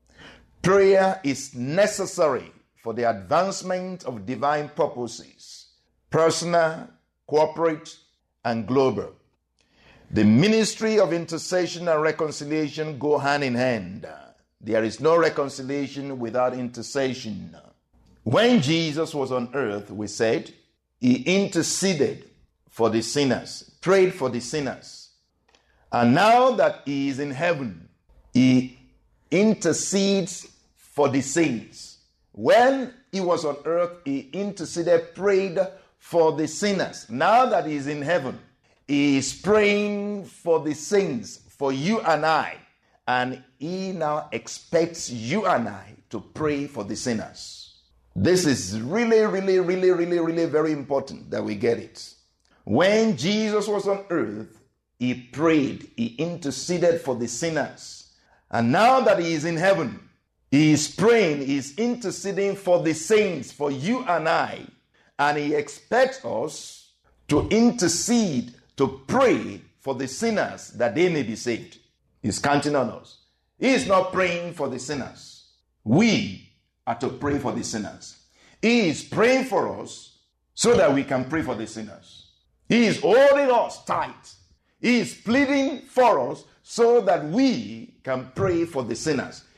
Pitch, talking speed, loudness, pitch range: 155 Hz, 135 wpm, -23 LUFS, 130-195 Hz